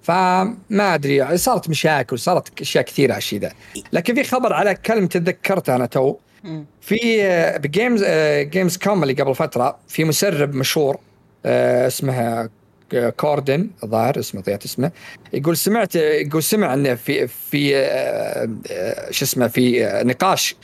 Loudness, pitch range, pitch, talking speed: -19 LUFS, 135-195 Hz, 155 Hz, 135 wpm